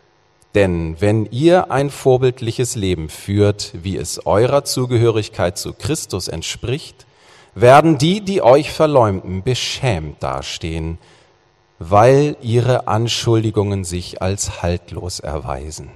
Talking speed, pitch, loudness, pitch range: 105 wpm, 105 Hz, -17 LUFS, 90-125 Hz